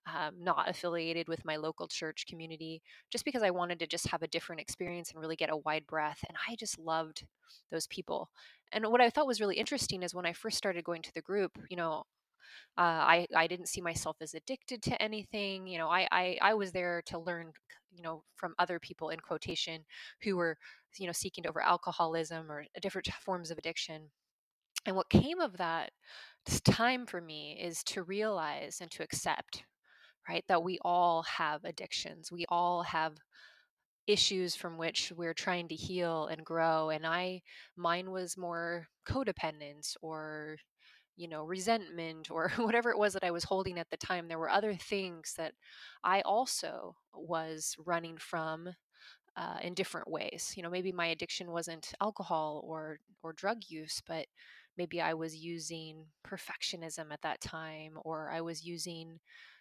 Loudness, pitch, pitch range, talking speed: -36 LUFS, 170 Hz, 160-185 Hz, 180 wpm